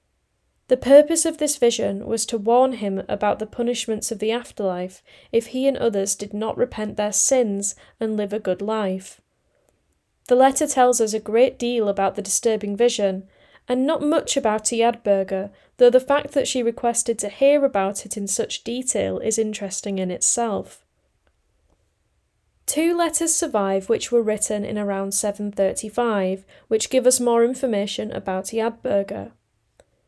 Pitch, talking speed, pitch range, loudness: 225 Hz, 155 wpm, 205-250 Hz, -21 LUFS